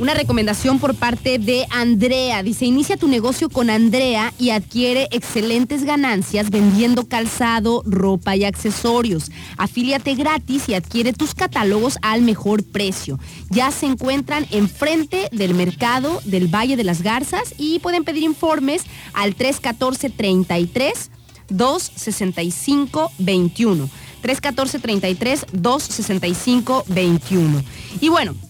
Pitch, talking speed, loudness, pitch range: 240 Hz, 105 wpm, -18 LUFS, 200-275 Hz